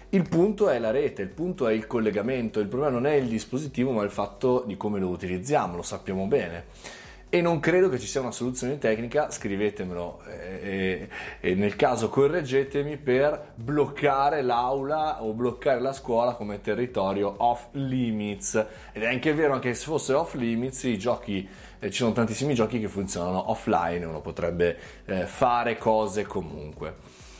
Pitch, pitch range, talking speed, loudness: 120 Hz, 100-135 Hz, 165 wpm, -27 LUFS